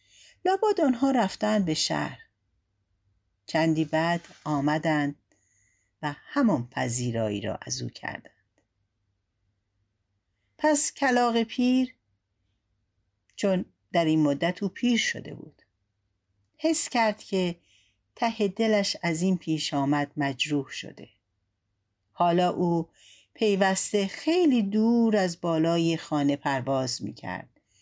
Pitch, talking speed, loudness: 155 Hz, 100 wpm, -26 LUFS